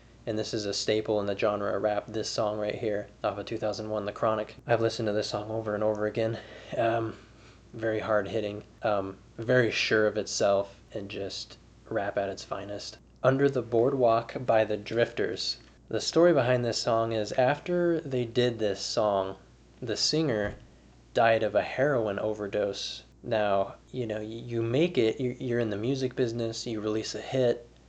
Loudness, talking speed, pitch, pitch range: -29 LUFS, 175 wpm, 110 Hz, 105-120 Hz